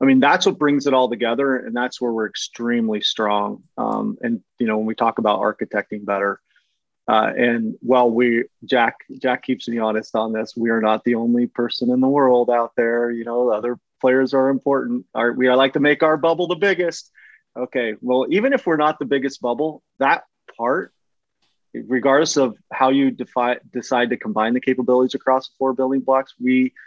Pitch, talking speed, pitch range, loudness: 125 Hz, 200 wpm, 115-135 Hz, -19 LUFS